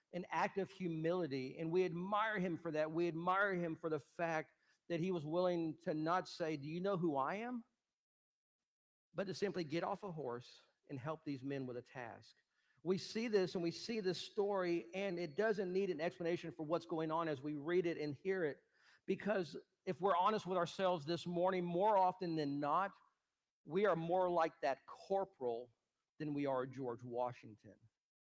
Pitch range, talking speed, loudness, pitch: 150-185 Hz, 195 wpm, -40 LUFS, 170 Hz